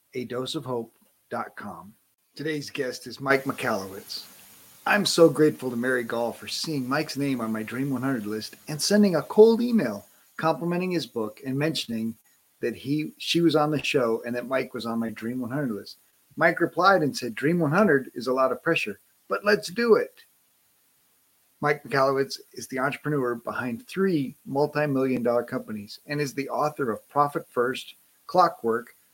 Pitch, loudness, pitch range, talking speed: 140 Hz, -25 LUFS, 125-160 Hz, 175 wpm